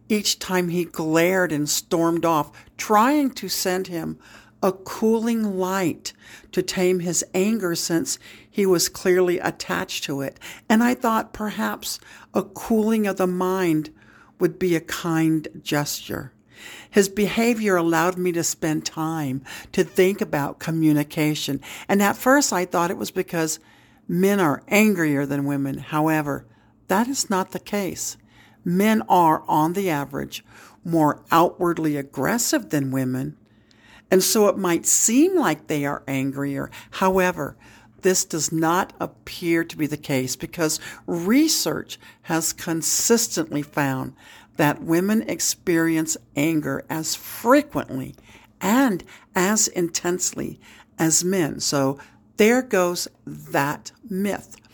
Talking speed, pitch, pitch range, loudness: 130 wpm, 170 Hz, 150-195 Hz, -22 LUFS